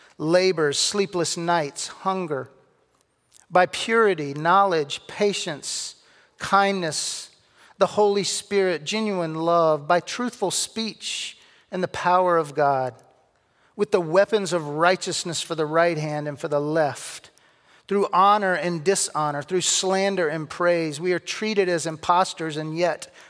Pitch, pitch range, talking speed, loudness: 175 Hz, 160-195 Hz, 130 wpm, -23 LUFS